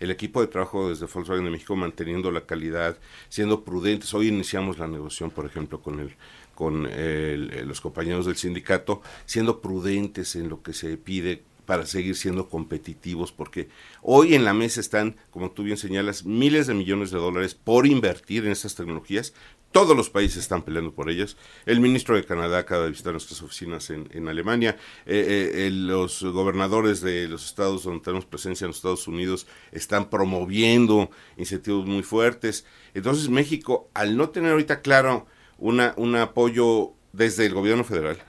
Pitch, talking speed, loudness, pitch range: 95 Hz, 175 wpm, -24 LUFS, 85-110 Hz